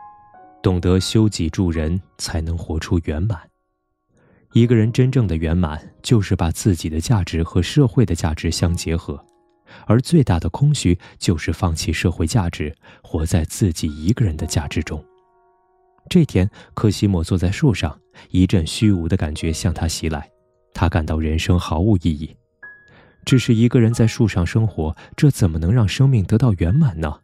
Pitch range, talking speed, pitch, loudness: 85-115 Hz, 250 characters per minute, 95 Hz, -19 LUFS